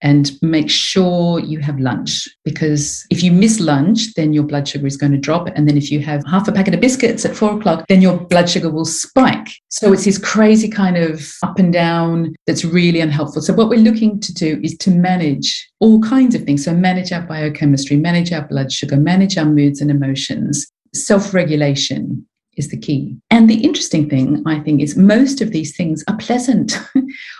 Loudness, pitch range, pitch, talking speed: -14 LUFS, 150-205 Hz, 170 Hz, 205 wpm